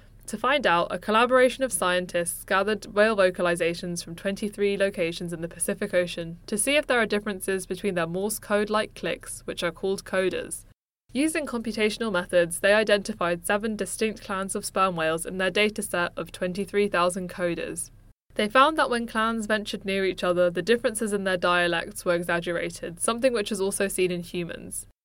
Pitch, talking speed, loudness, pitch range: 195 Hz, 175 wpm, -25 LUFS, 175-215 Hz